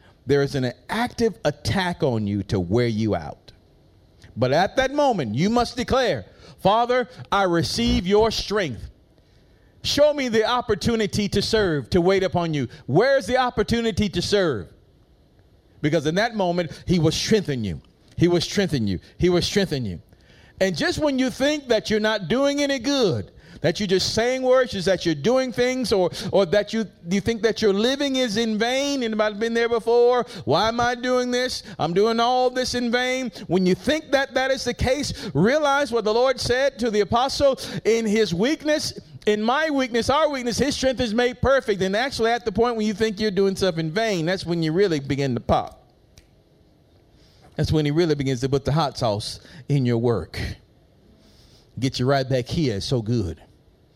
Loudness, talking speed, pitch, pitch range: -22 LUFS, 190 wpm, 215 Hz, 160-245 Hz